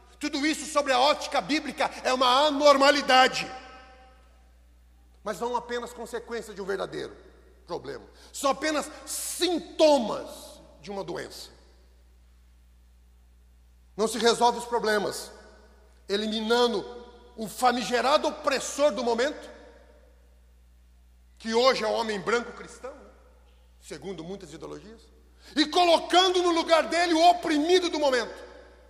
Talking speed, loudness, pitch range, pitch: 110 wpm, -25 LUFS, 175-295 Hz, 240 Hz